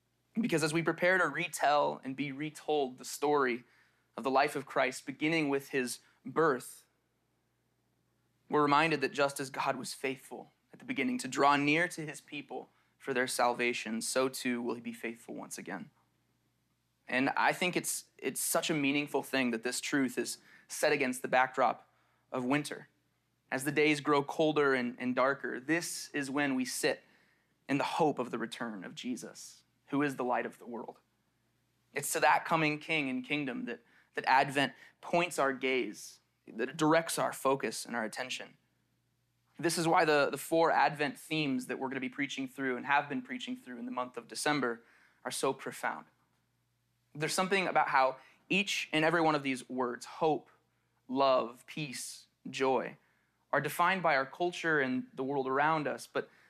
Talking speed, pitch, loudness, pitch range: 180 wpm, 135 Hz, -32 LUFS, 125-150 Hz